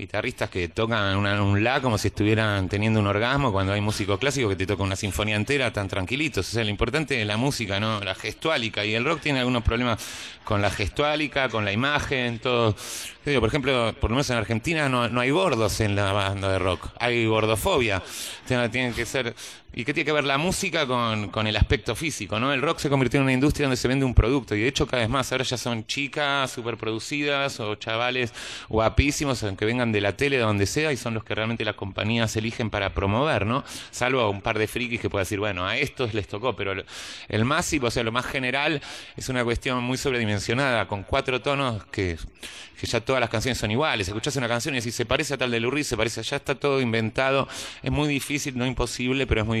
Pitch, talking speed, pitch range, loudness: 120 Hz, 230 wpm, 105-135 Hz, -24 LUFS